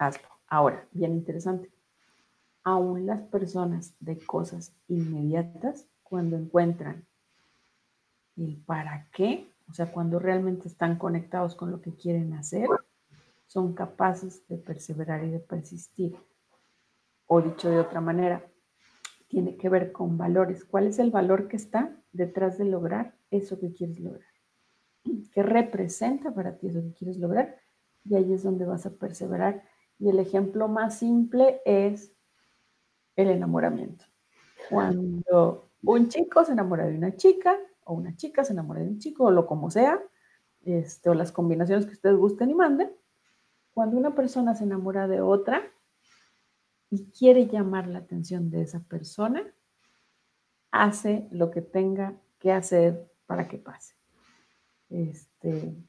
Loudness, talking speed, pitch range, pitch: -27 LUFS, 140 wpm, 170-205 Hz, 185 Hz